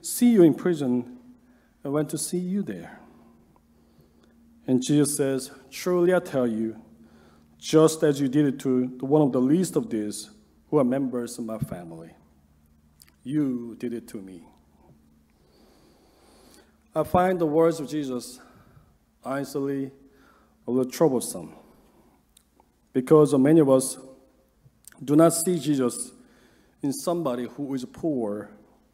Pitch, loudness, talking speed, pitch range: 130 Hz, -24 LUFS, 130 wpm, 110-155 Hz